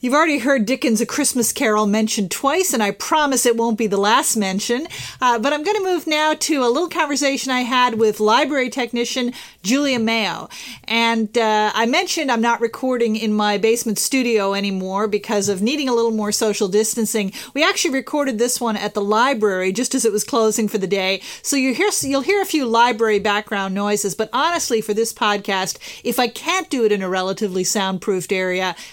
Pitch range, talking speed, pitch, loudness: 210-270 Hz, 200 wpm, 230 Hz, -18 LUFS